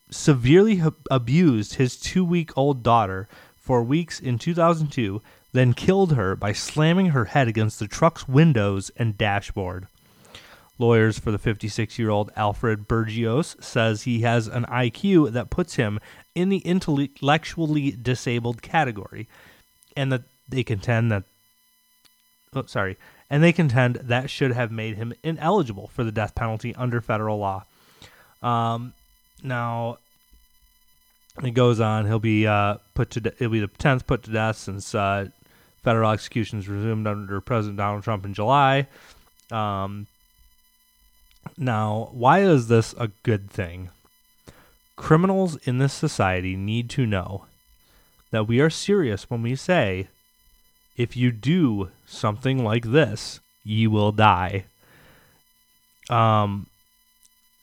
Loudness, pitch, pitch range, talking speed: -23 LUFS, 115 Hz, 105-135 Hz, 130 wpm